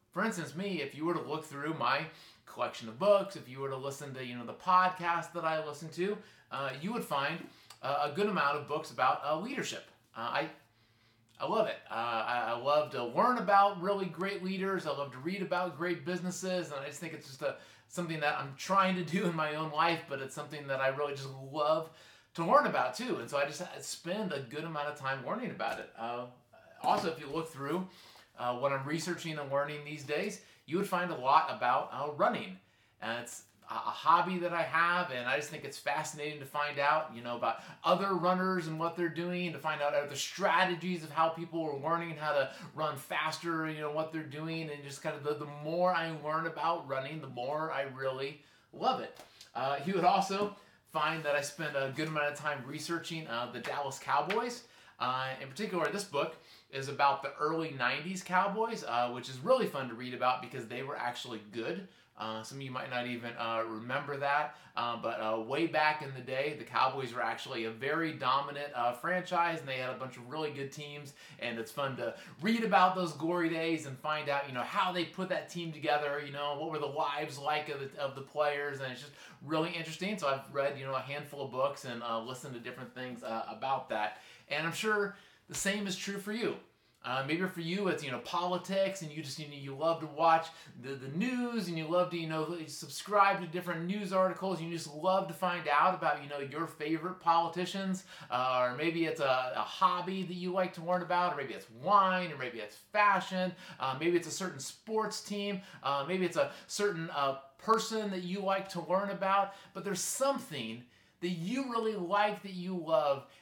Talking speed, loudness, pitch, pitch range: 225 wpm, -34 LUFS, 155 Hz, 135-180 Hz